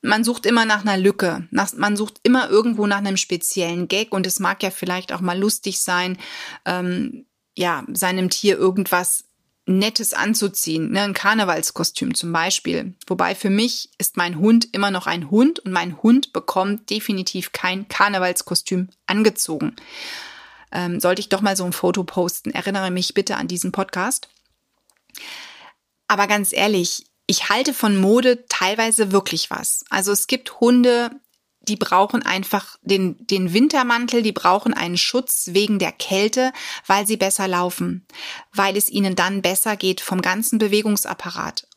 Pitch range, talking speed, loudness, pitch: 185-225 Hz, 155 wpm, -19 LUFS, 200 Hz